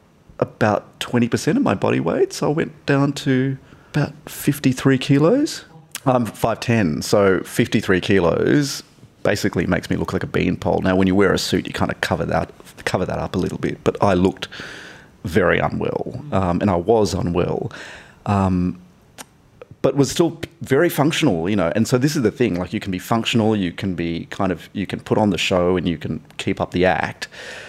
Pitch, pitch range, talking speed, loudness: 115 Hz, 95-140 Hz, 195 wpm, -20 LUFS